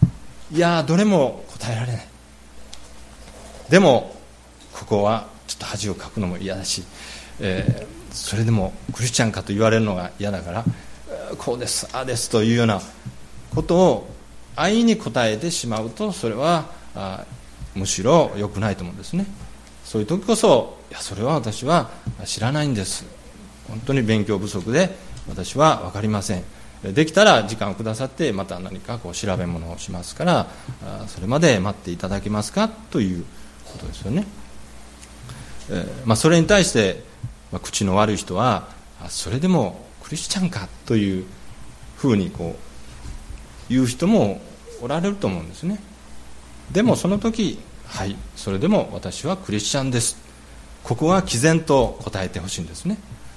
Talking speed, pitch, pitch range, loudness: 305 characters per minute, 110 Hz, 90-145 Hz, -21 LUFS